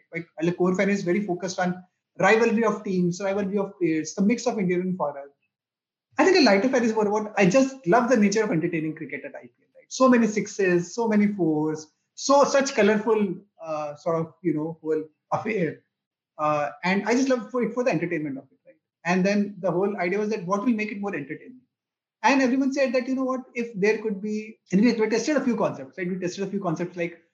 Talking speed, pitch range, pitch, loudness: 230 wpm, 170-225 Hz, 200 Hz, -24 LUFS